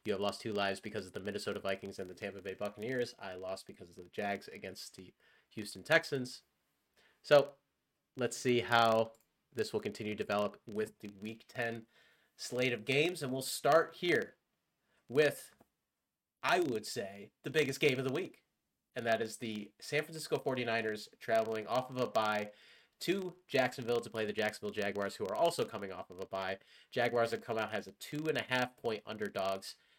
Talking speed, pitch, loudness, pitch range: 190 wpm, 115 Hz, -36 LUFS, 105-130 Hz